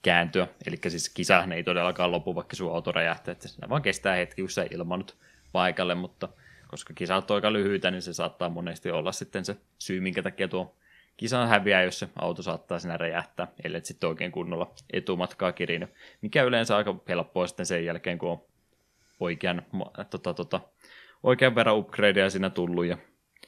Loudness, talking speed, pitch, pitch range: -28 LUFS, 170 wpm, 90 Hz, 90-100 Hz